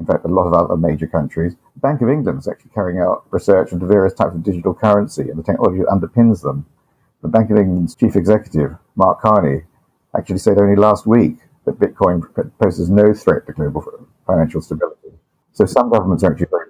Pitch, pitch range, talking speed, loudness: 100 Hz, 85-105 Hz, 200 wpm, -16 LUFS